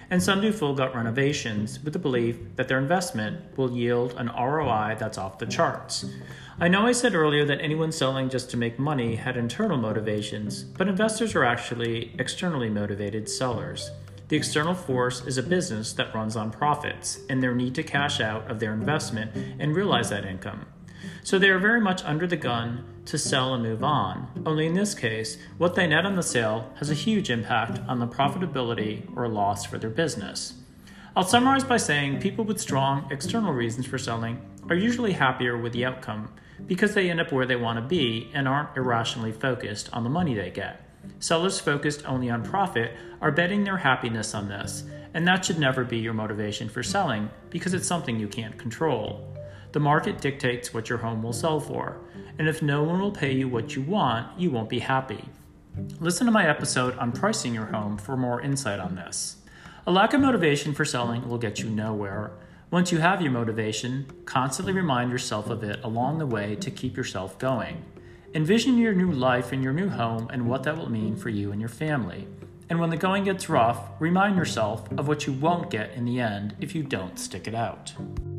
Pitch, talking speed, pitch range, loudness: 130 Hz, 200 wpm, 115-160 Hz, -26 LUFS